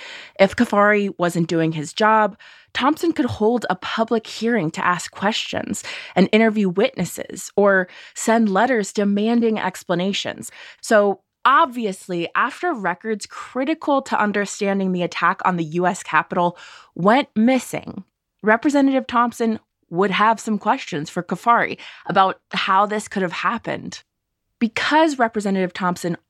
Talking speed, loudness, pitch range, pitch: 125 wpm, -20 LUFS, 185-235 Hz, 210 Hz